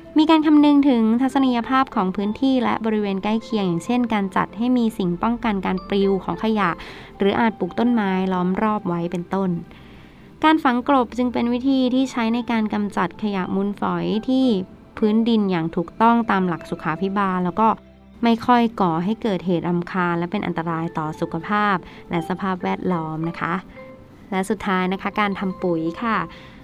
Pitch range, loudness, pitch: 180-230 Hz, -21 LUFS, 200 Hz